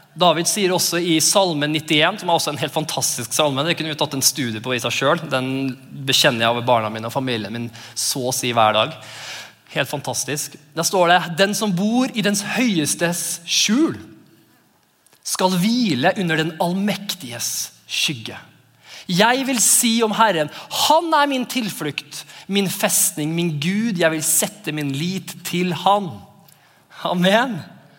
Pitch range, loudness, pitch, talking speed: 140-200 Hz, -19 LUFS, 165 Hz, 160 wpm